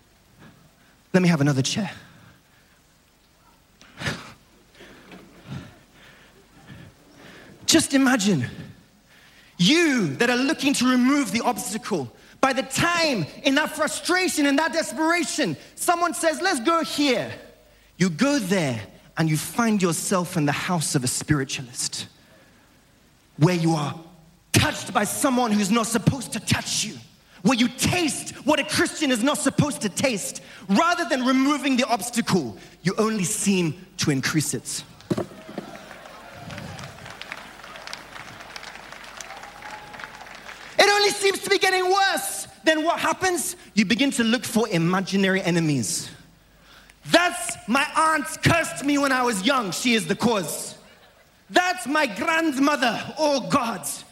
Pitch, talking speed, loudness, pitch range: 245 Hz, 125 wpm, -22 LUFS, 180-305 Hz